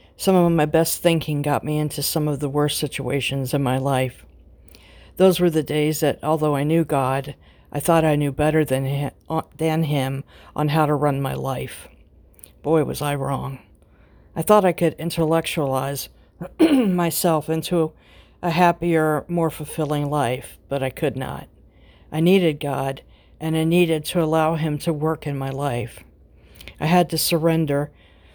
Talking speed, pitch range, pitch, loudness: 160 wpm, 135-160 Hz, 150 Hz, -21 LUFS